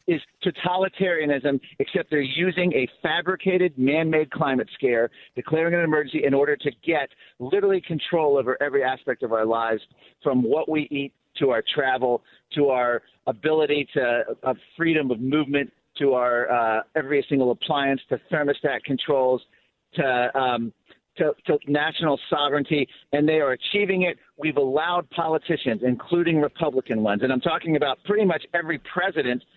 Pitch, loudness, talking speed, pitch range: 145 Hz, -23 LUFS, 150 wpm, 130-165 Hz